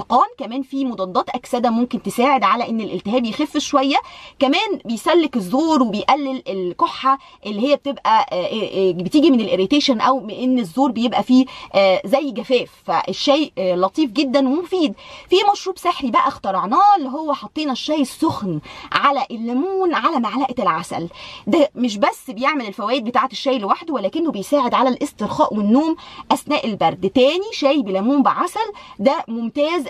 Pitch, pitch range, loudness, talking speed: 265 Hz, 235-295 Hz, -19 LUFS, 145 wpm